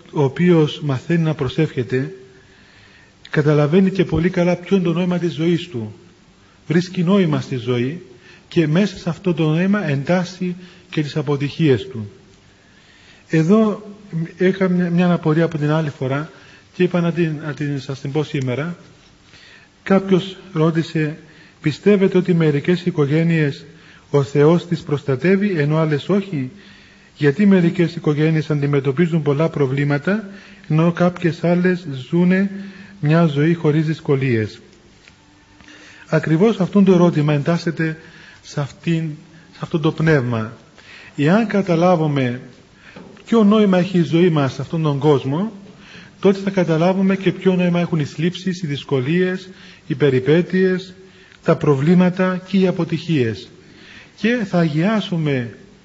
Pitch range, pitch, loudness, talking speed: 145-180 Hz, 165 Hz, -18 LUFS, 130 wpm